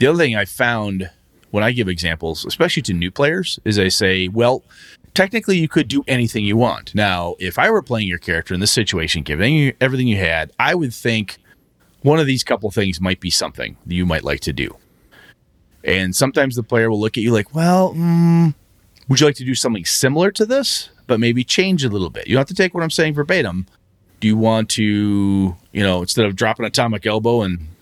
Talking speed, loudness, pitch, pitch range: 220 wpm, -17 LUFS, 110 Hz, 95-140 Hz